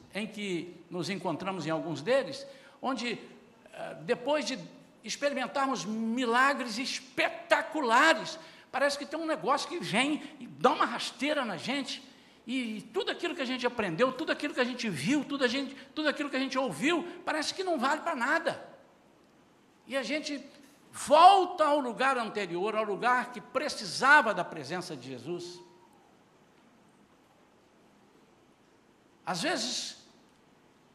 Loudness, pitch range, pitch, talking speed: -30 LUFS, 225-290 Hz, 265 Hz, 140 wpm